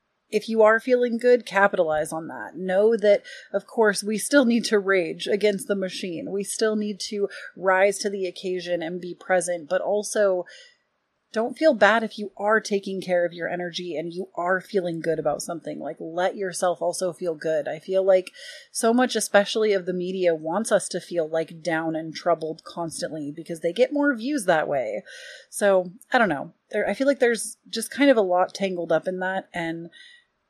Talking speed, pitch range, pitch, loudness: 200 wpm, 175-220 Hz, 195 Hz, -24 LUFS